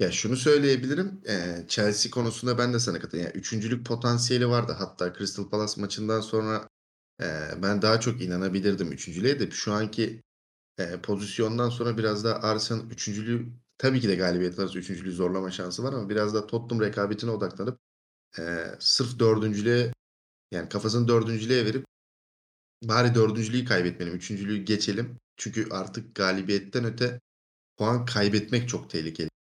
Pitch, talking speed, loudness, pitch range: 110 Hz, 140 wpm, -27 LUFS, 95-120 Hz